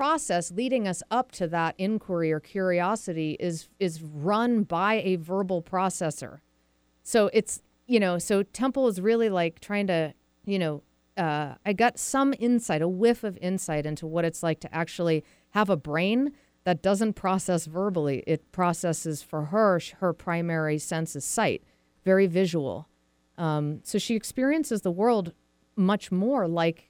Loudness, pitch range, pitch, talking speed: -27 LUFS, 160-210 Hz, 180 Hz, 160 wpm